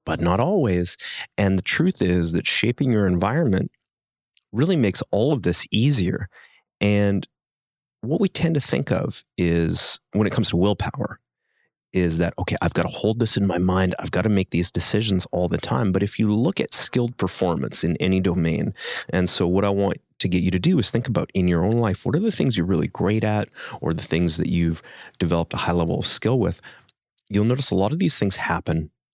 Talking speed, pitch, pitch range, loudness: 215 wpm, 95 Hz, 90-110 Hz, -22 LUFS